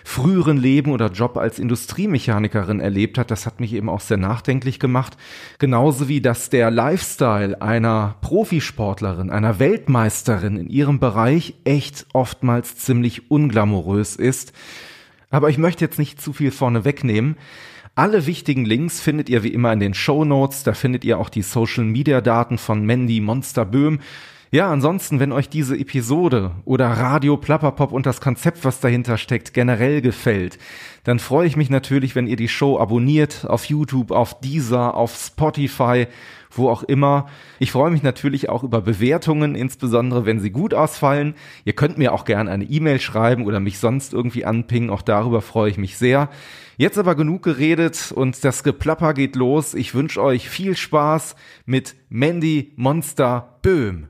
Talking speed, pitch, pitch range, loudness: 165 wpm, 130 Hz, 115-145 Hz, -19 LUFS